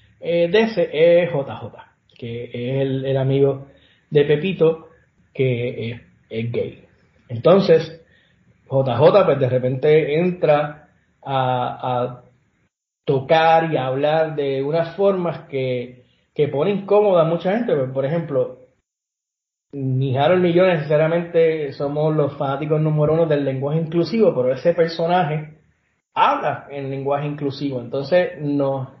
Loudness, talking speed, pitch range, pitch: -19 LUFS, 130 wpm, 135-165 Hz, 145 Hz